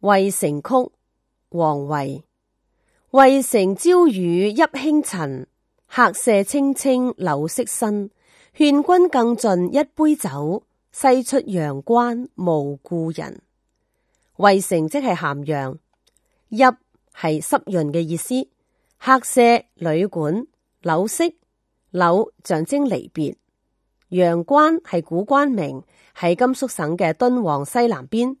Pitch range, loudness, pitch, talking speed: 165-260 Hz, -19 LUFS, 200 Hz, 155 characters per minute